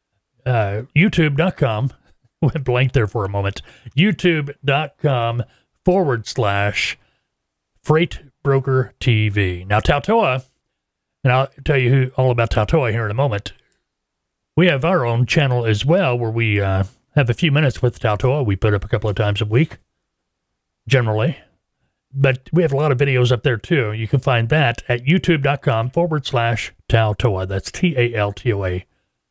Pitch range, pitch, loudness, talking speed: 110-145 Hz, 125 Hz, -18 LUFS, 165 wpm